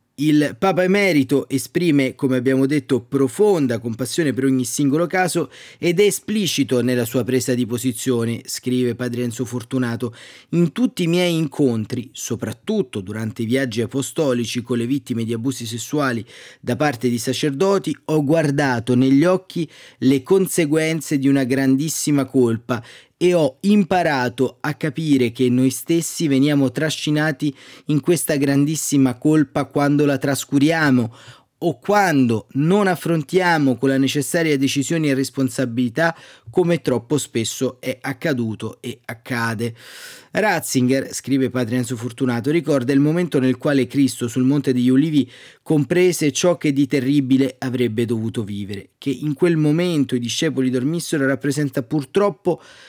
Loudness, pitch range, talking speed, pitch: -19 LUFS, 125-155 Hz, 135 wpm, 135 Hz